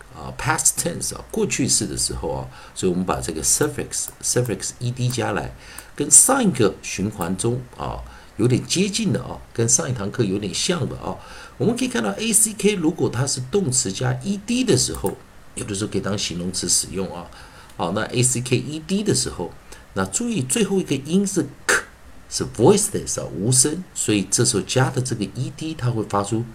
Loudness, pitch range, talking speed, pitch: -21 LUFS, 105-170 Hz, 335 characters per minute, 125 Hz